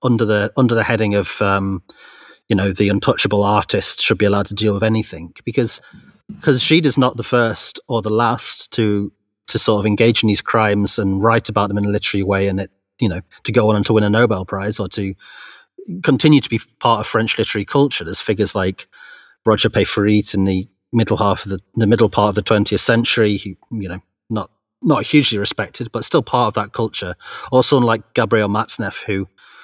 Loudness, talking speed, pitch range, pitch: -16 LUFS, 210 wpm, 100-115 Hz, 105 Hz